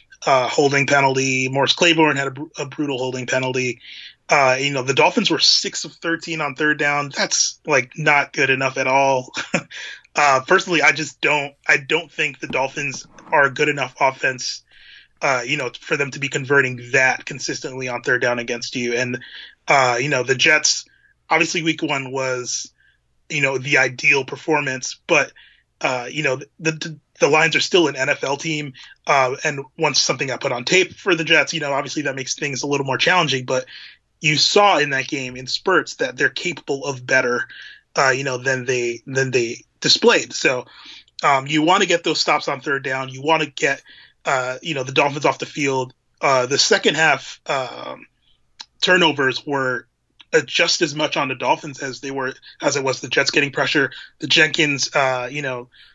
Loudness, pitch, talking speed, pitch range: -18 LUFS, 140 Hz, 195 wpm, 130-155 Hz